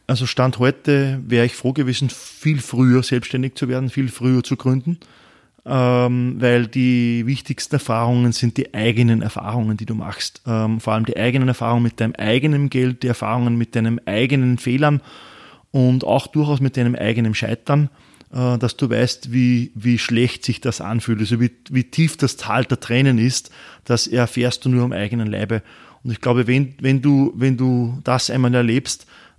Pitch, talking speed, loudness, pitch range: 125 Hz, 175 wpm, -19 LUFS, 120-130 Hz